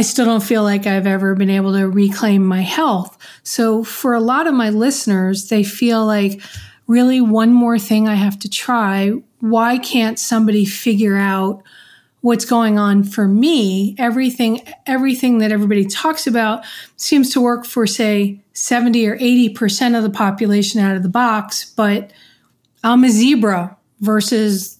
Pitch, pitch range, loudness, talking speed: 220 Hz, 200-240 Hz, -15 LUFS, 160 wpm